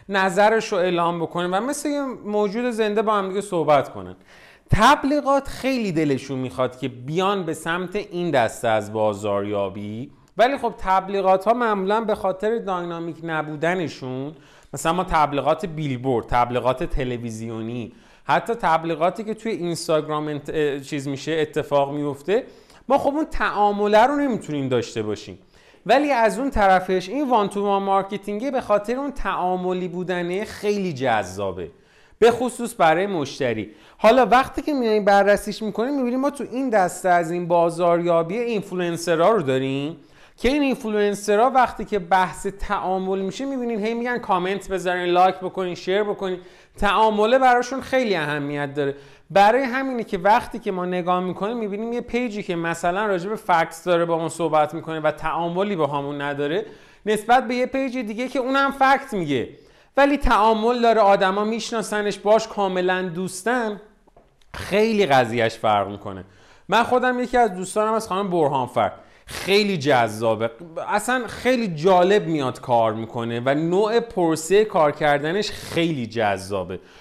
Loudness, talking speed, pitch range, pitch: -21 LUFS, 145 wpm, 155-220 Hz, 190 Hz